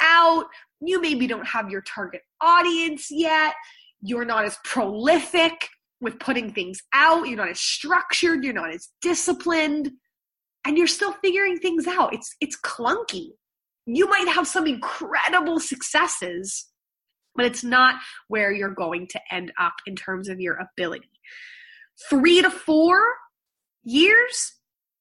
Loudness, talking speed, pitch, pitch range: -21 LUFS, 140 wpm, 315 Hz, 235-355 Hz